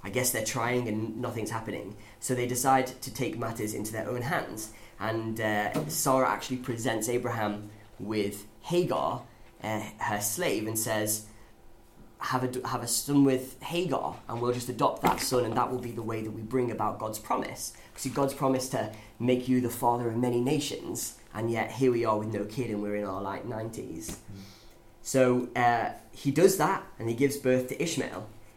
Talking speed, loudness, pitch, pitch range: 190 wpm, -30 LUFS, 115 Hz, 110-130 Hz